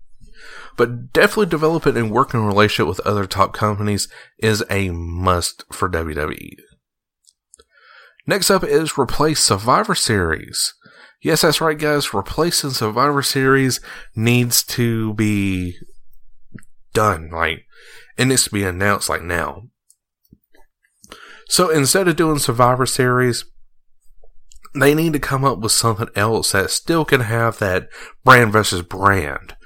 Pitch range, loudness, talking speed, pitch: 100-140 Hz, -17 LUFS, 125 wpm, 115 Hz